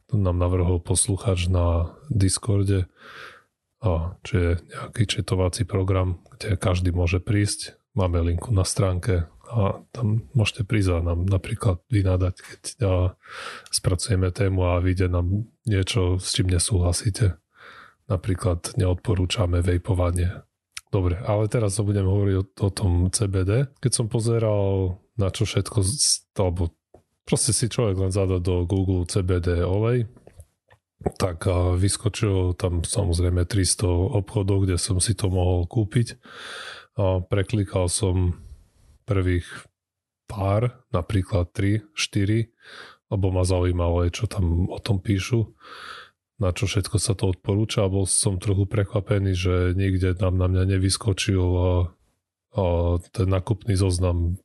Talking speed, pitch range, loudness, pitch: 125 wpm, 90-105 Hz, -24 LUFS, 95 Hz